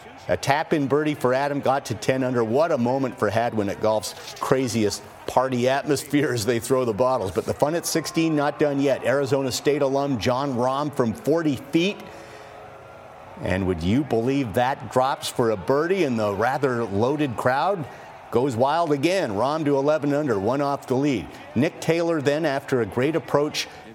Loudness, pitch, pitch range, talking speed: -23 LUFS, 135 Hz, 125-145 Hz, 185 wpm